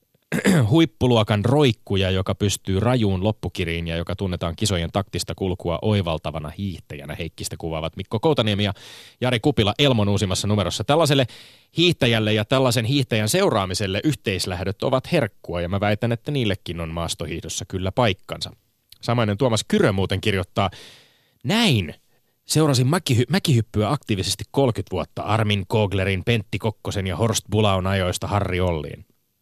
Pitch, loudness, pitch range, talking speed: 105 Hz, -22 LUFS, 95-120 Hz, 130 wpm